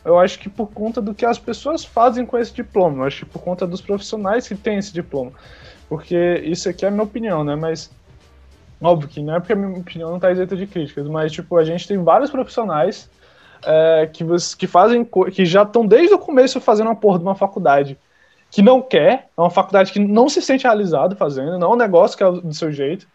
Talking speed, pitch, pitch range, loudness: 235 wpm, 185 Hz, 165-225 Hz, -17 LUFS